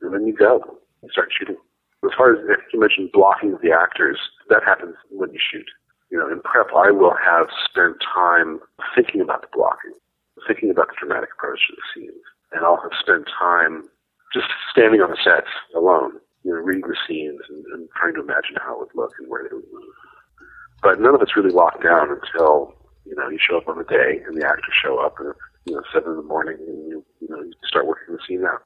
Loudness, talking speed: -18 LUFS, 230 wpm